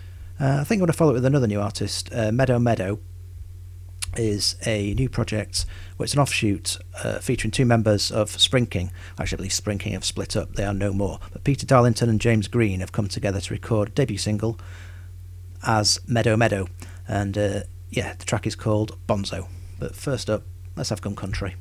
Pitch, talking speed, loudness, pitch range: 100 Hz, 200 wpm, -23 LUFS, 90-115 Hz